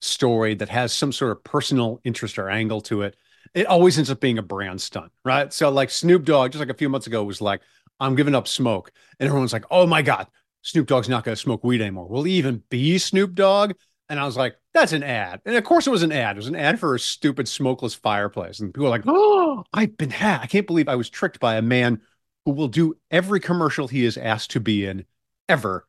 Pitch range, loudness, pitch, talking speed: 115-165 Hz, -21 LUFS, 135 Hz, 255 wpm